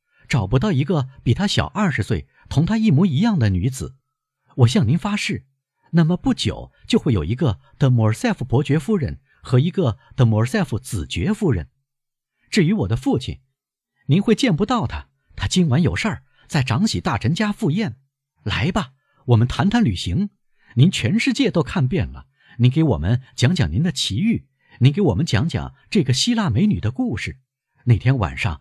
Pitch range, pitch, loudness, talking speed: 120-185 Hz, 135 Hz, -20 LUFS, 265 characters per minute